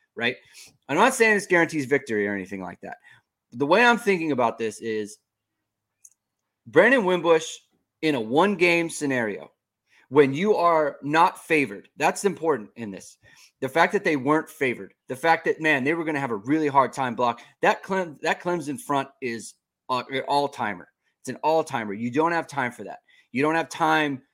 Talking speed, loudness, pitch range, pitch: 180 wpm, -23 LUFS, 115-165 Hz, 145 Hz